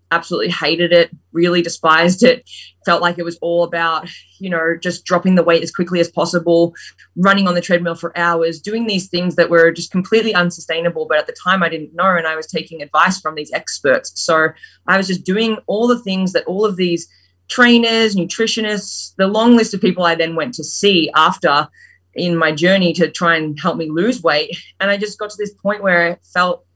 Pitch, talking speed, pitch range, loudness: 175 Hz, 215 wpm, 165-195 Hz, -15 LUFS